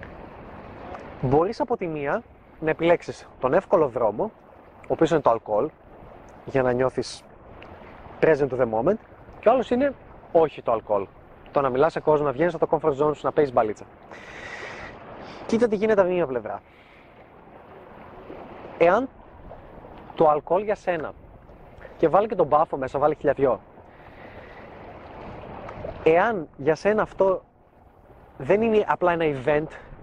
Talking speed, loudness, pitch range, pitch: 140 wpm, -23 LUFS, 135-185 Hz, 155 Hz